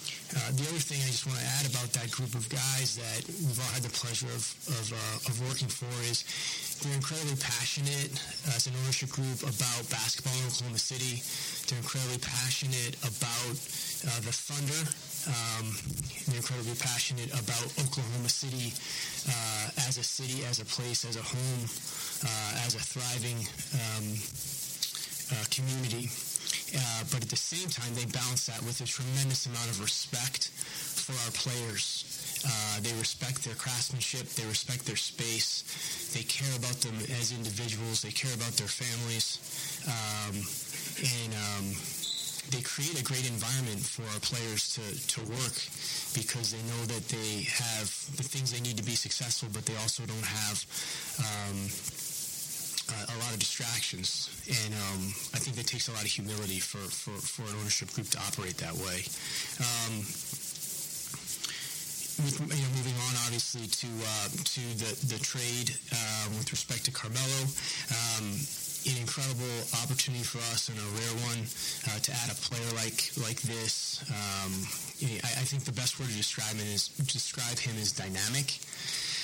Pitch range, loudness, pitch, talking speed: 115-140 Hz, -32 LUFS, 125 Hz, 165 wpm